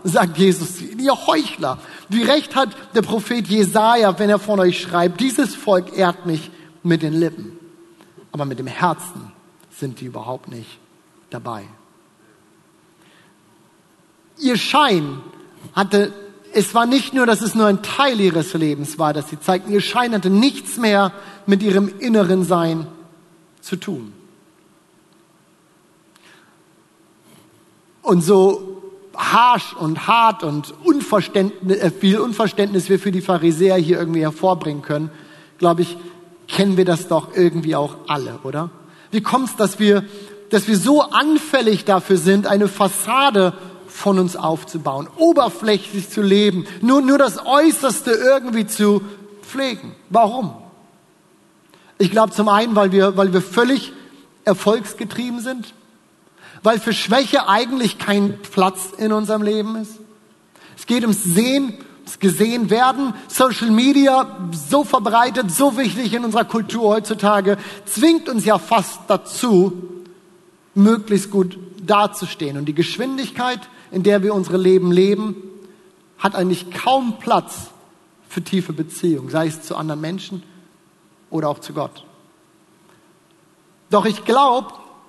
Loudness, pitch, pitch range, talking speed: -17 LUFS, 195 Hz, 175-225 Hz, 130 wpm